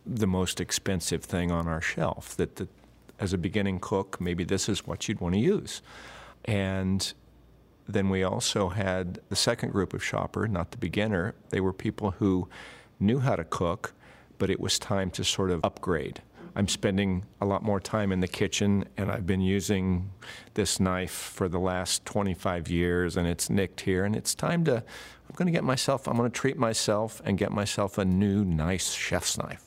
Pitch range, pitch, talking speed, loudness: 90-105 Hz, 95 Hz, 195 wpm, -28 LUFS